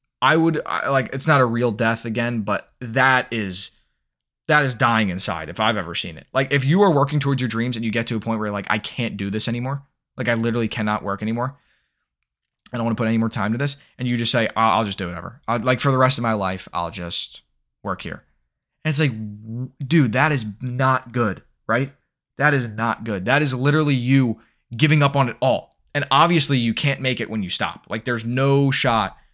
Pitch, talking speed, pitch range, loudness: 120 Hz, 240 wpm, 110-135 Hz, -21 LUFS